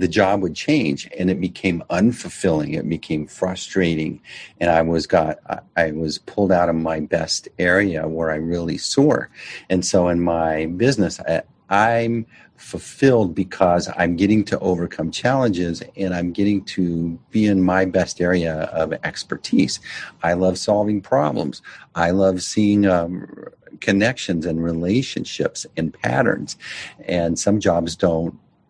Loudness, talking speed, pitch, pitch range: -20 LUFS, 145 wpm, 90 Hz, 85-95 Hz